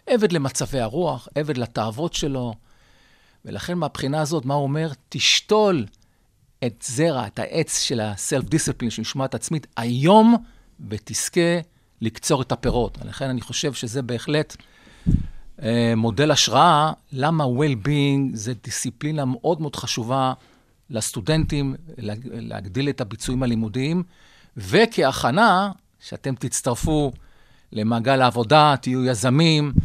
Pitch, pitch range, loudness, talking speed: 135 Hz, 120-155 Hz, -21 LUFS, 110 wpm